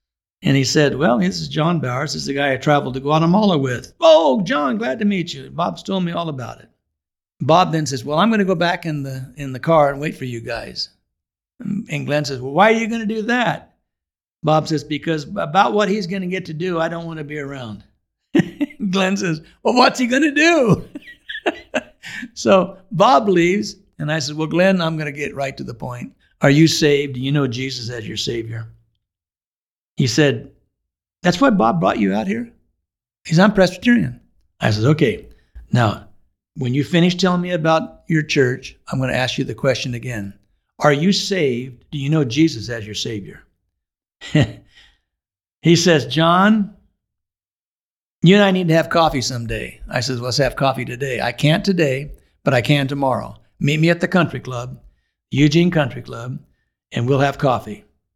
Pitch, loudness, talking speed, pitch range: 150 Hz, -18 LUFS, 195 wpm, 130-185 Hz